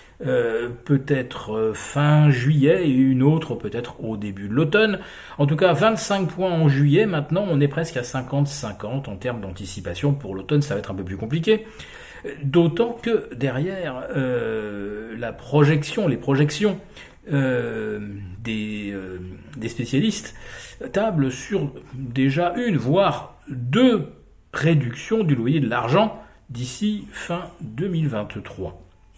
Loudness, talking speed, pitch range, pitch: -22 LUFS, 130 wpm, 115-175 Hz, 140 Hz